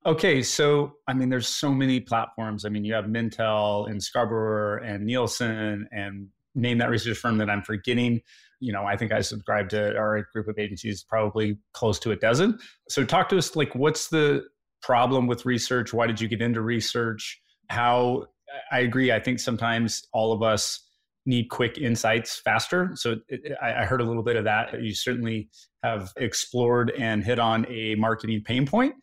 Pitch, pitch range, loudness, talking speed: 115 Hz, 110-125 Hz, -25 LUFS, 185 wpm